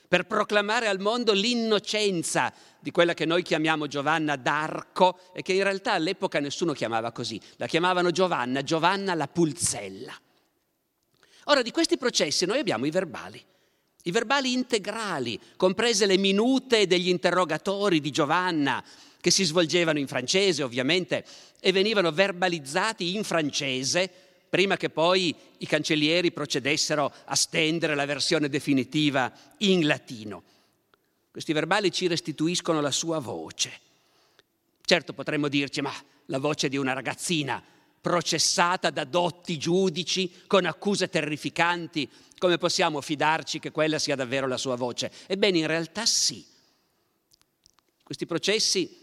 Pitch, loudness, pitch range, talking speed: 170 Hz, -25 LUFS, 150-190 Hz, 130 wpm